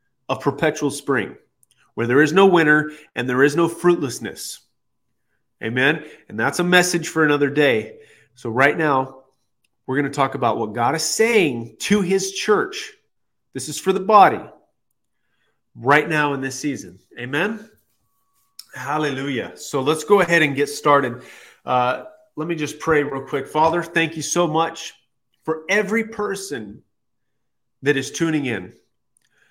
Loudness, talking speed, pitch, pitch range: -19 LUFS, 150 wpm, 145 Hz, 130-170 Hz